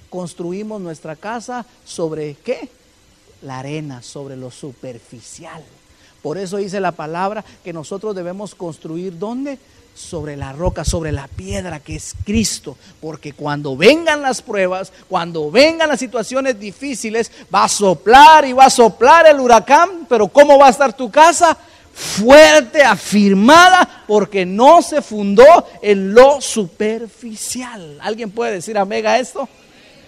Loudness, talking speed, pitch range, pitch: -12 LUFS, 140 wpm, 175-265 Hz, 215 Hz